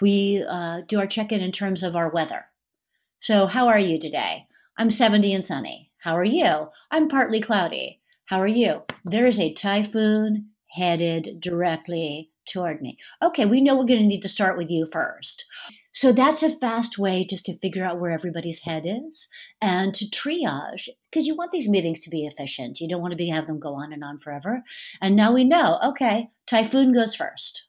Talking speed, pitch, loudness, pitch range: 200 wpm, 200 Hz, -23 LUFS, 175-240 Hz